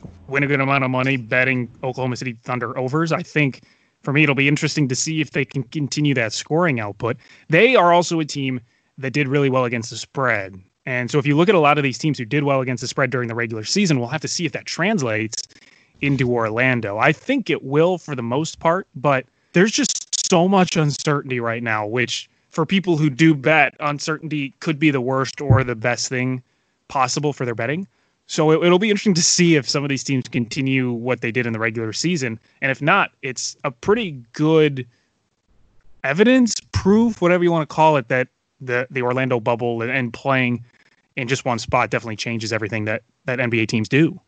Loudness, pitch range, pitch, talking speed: -19 LUFS, 120-155 Hz, 135 Hz, 215 wpm